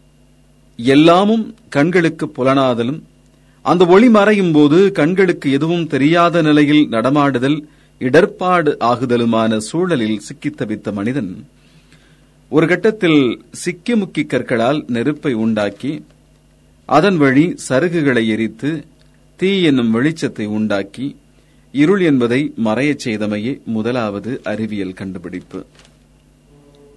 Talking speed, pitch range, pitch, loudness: 90 wpm, 110-160 Hz, 135 Hz, -15 LUFS